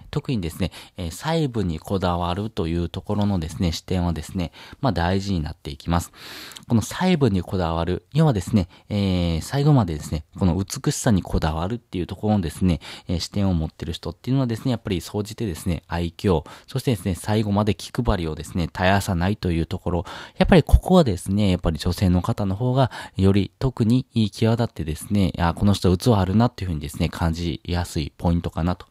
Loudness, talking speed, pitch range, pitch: -23 LUFS, 430 characters per minute, 85-110 Hz, 95 Hz